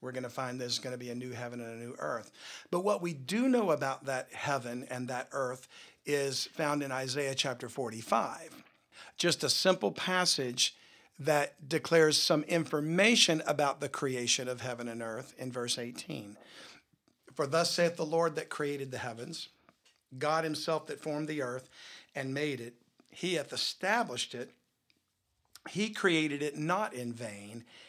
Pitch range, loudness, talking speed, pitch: 125-160 Hz, -32 LUFS, 170 wpm, 140 Hz